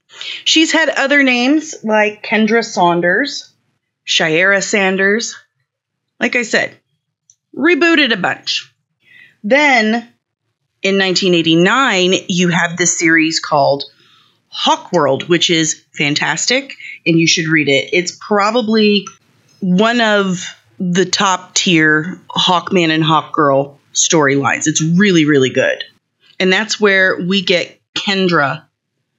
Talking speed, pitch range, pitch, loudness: 115 wpm, 155-215 Hz, 180 Hz, -13 LUFS